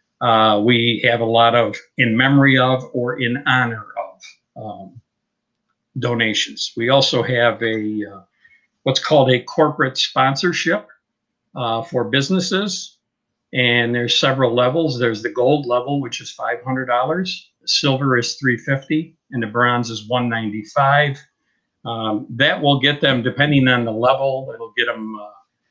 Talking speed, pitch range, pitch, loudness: 140 wpm, 115-140 Hz, 125 Hz, -17 LUFS